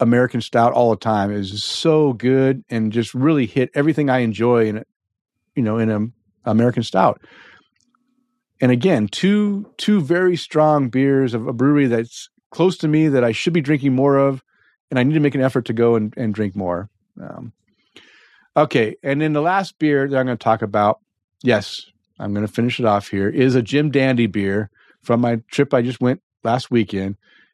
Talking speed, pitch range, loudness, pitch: 200 wpm, 110-145 Hz, -18 LUFS, 125 Hz